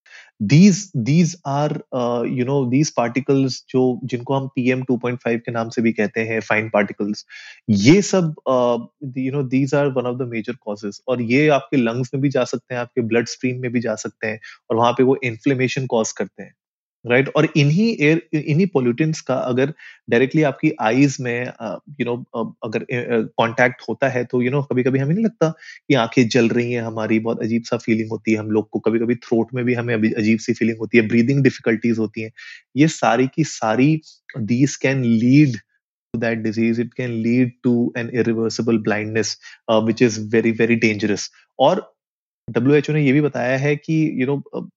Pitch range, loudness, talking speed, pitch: 115-140 Hz, -19 LUFS, 210 wpm, 125 Hz